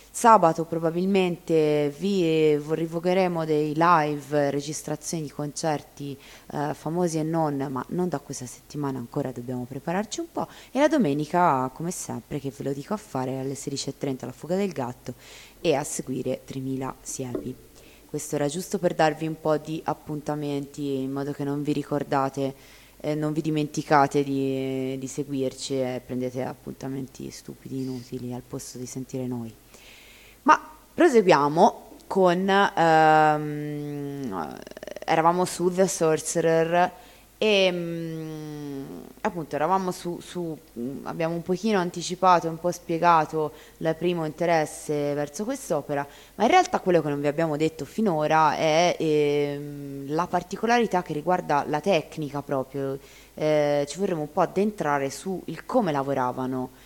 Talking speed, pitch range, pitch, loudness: 140 wpm, 140-175 Hz, 150 Hz, -25 LUFS